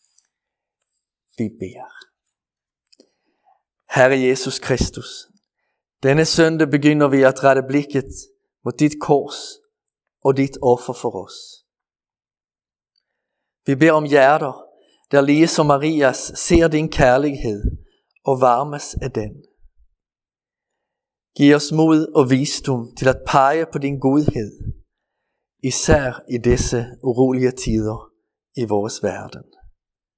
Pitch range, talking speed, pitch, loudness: 125-155 Hz, 105 wpm, 135 Hz, -17 LUFS